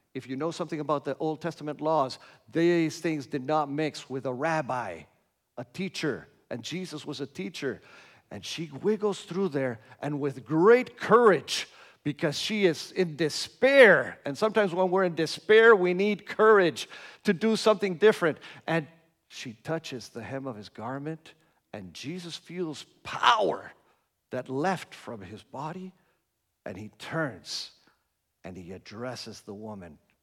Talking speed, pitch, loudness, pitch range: 150 wpm, 155 Hz, -26 LUFS, 130-180 Hz